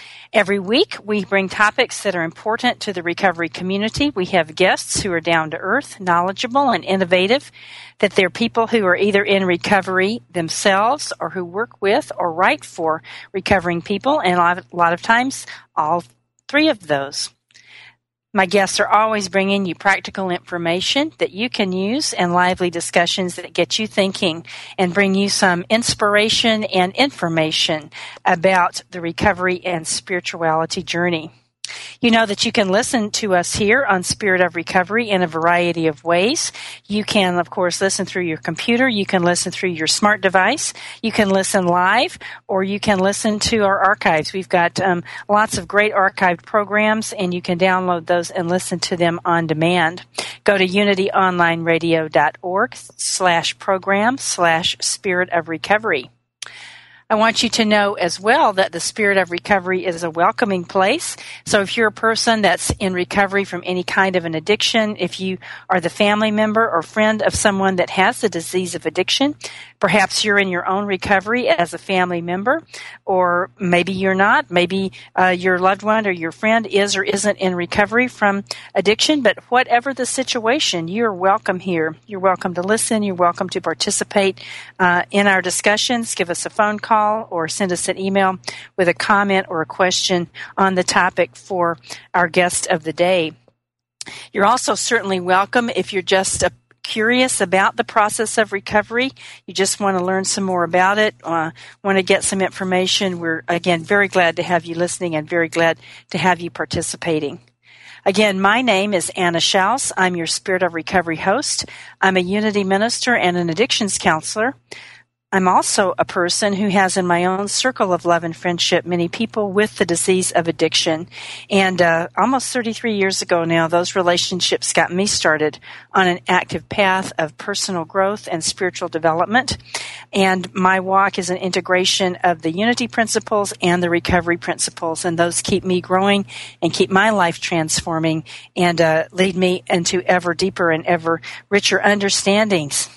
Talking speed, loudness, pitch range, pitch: 175 wpm, -17 LUFS, 175-205 Hz, 190 Hz